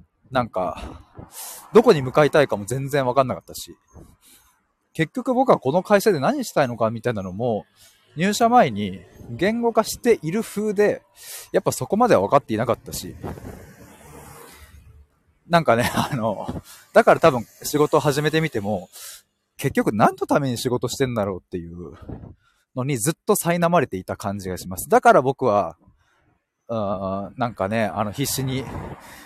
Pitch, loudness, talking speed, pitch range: 125 Hz, -21 LUFS, 300 characters per minute, 100-160 Hz